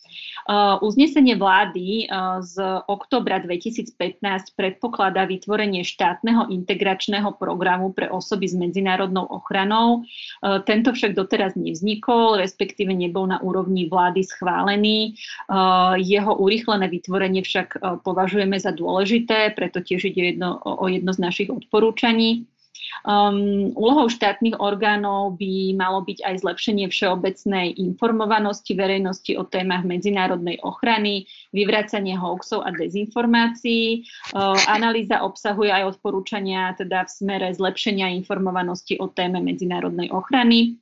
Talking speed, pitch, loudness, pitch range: 120 wpm, 195 Hz, -21 LUFS, 185-215 Hz